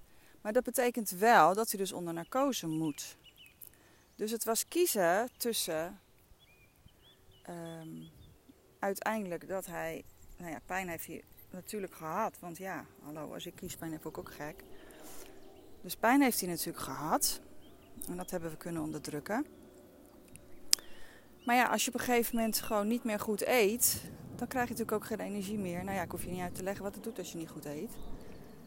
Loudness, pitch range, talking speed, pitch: -34 LUFS, 170-230 Hz, 180 wpm, 195 Hz